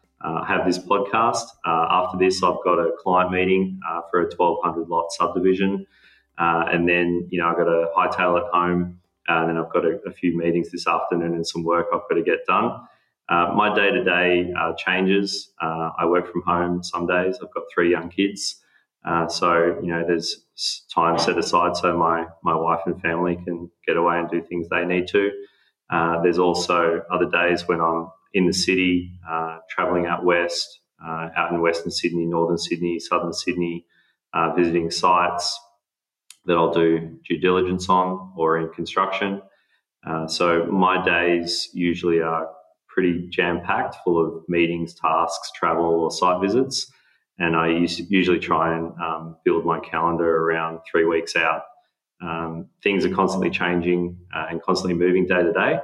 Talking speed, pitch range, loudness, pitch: 180 wpm, 85-90 Hz, -22 LUFS, 85 Hz